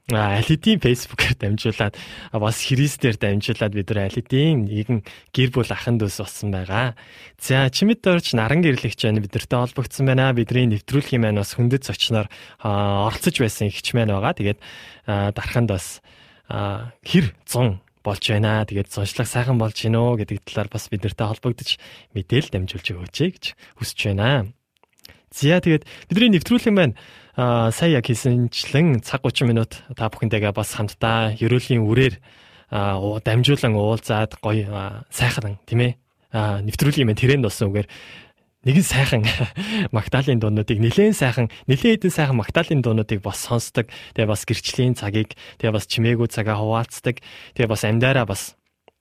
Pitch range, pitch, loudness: 105-130 Hz, 115 Hz, -21 LUFS